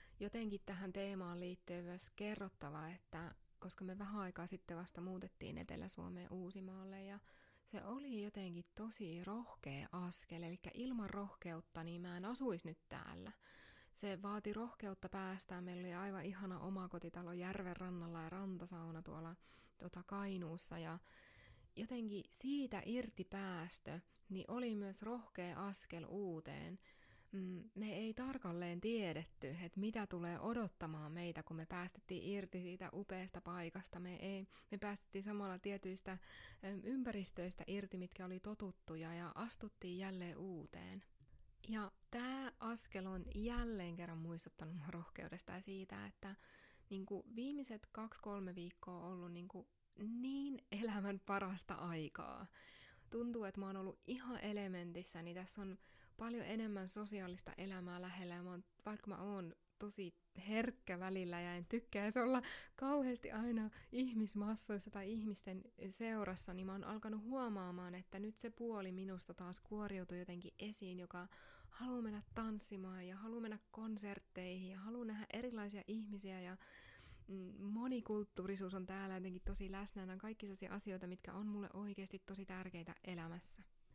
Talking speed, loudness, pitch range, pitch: 135 wpm, -48 LUFS, 180-210 Hz, 190 Hz